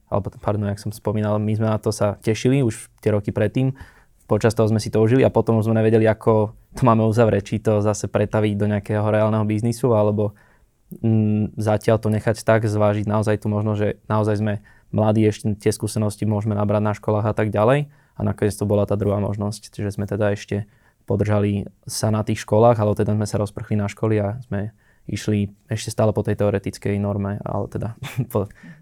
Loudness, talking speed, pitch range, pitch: -21 LUFS, 200 wpm, 105-110 Hz, 105 Hz